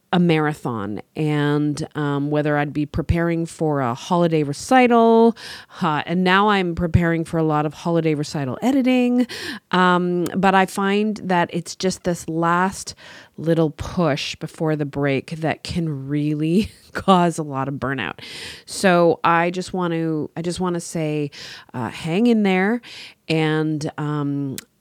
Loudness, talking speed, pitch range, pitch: -20 LUFS, 150 wpm, 150-185 Hz, 165 Hz